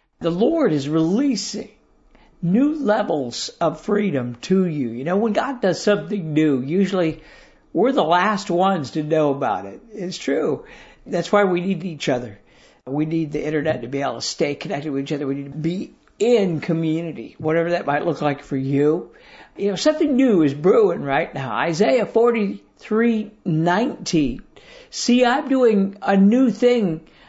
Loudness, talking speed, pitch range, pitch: -20 LUFS, 170 wpm, 155-215 Hz, 180 Hz